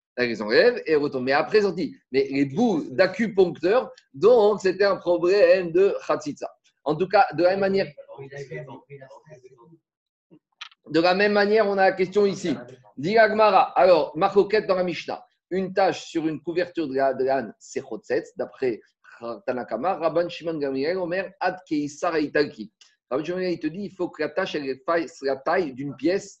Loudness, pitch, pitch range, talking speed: -23 LUFS, 180 Hz, 150-205 Hz, 175 wpm